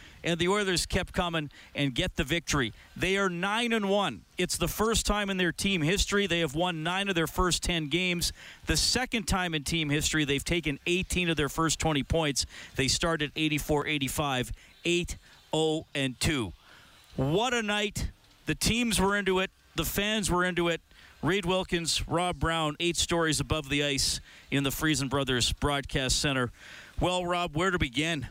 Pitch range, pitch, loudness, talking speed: 145-180 Hz, 165 Hz, -28 LUFS, 175 wpm